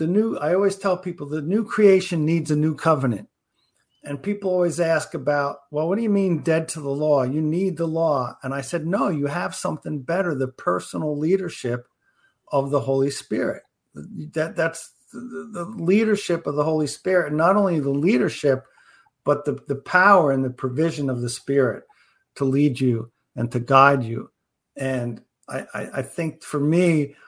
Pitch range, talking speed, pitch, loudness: 140-175 Hz, 185 wpm, 155 Hz, -22 LUFS